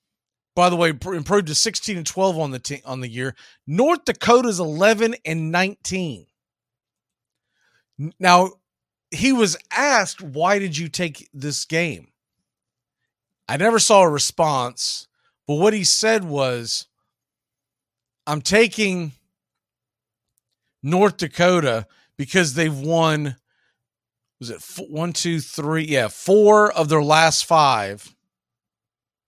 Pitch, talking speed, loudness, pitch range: 160 Hz, 120 wpm, -19 LUFS, 130-190 Hz